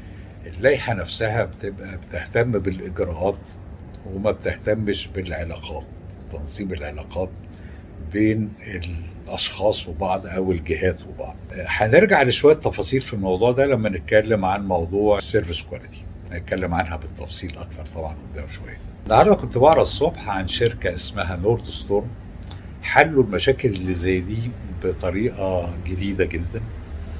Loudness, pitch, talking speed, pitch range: -22 LUFS, 95 Hz, 115 wpm, 85-105 Hz